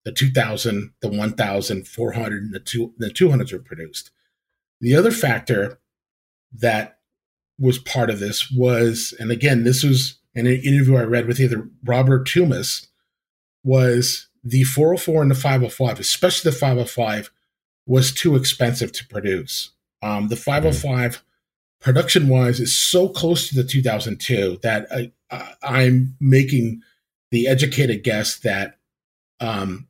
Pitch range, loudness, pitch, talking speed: 115-135 Hz, -19 LUFS, 125 Hz, 135 wpm